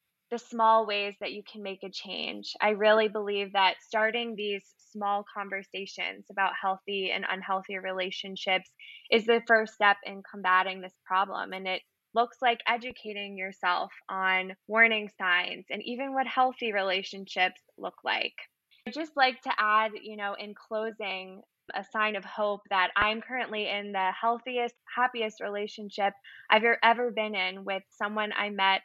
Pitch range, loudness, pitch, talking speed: 195-225 Hz, -29 LUFS, 205 Hz, 160 wpm